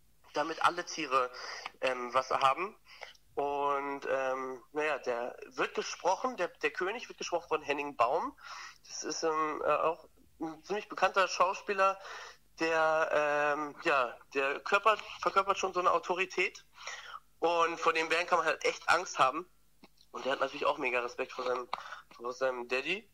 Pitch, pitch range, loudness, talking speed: 160 Hz, 140-185 Hz, -32 LUFS, 160 wpm